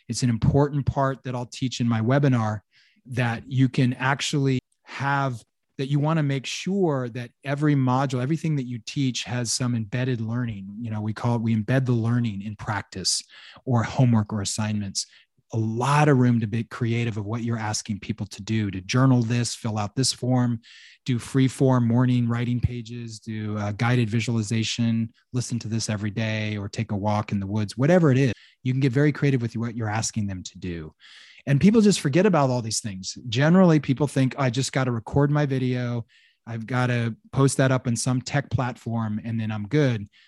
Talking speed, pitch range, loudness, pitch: 205 wpm, 110-135 Hz, -24 LUFS, 120 Hz